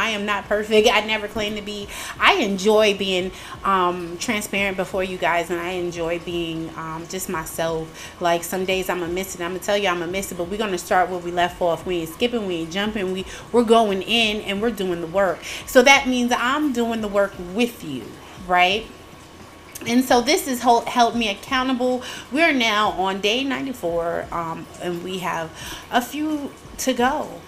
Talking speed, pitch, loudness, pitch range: 210 wpm, 195 Hz, -21 LUFS, 175-235 Hz